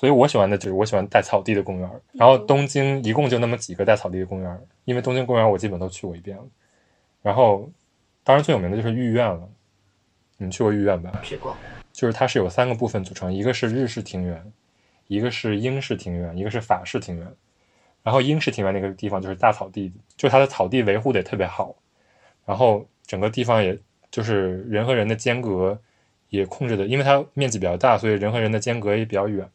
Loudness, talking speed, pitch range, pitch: -22 LUFS, 340 characters per minute, 95-125 Hz, 105 Hz